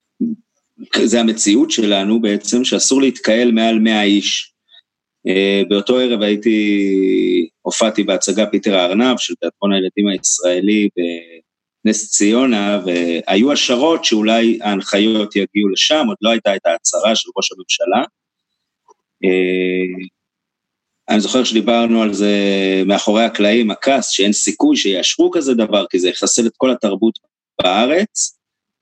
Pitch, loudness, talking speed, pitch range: 105 Hz, -15 LUFS, 120 wpm, 100-120 Hz